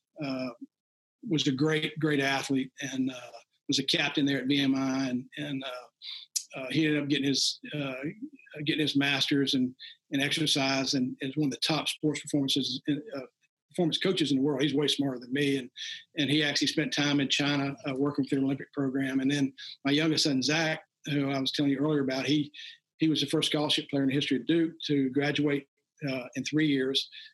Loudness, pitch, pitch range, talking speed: -29 LUFS, 145 Hz, 135-155 Hz, 210 wpm